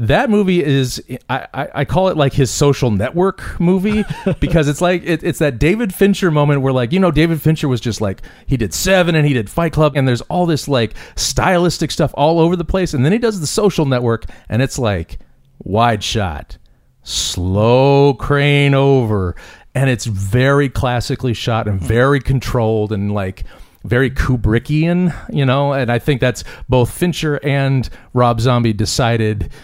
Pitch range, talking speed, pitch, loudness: 115-160 Hz, 180 wpm, 135 Hz, -15 LUFS